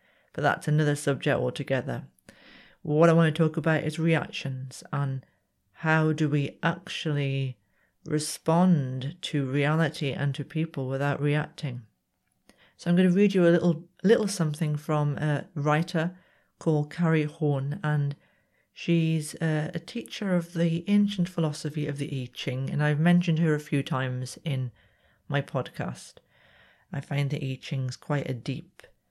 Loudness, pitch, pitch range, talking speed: -27 LUFS, 150 Hz, 140-165 Hz, 150 wpm